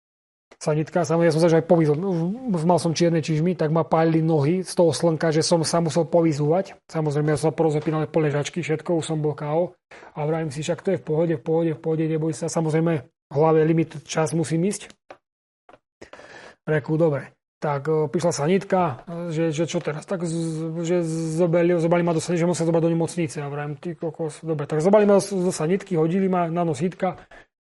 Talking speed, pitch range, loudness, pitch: 195 wpm, 160-175 Hz, -22 LUFS, 165 Hz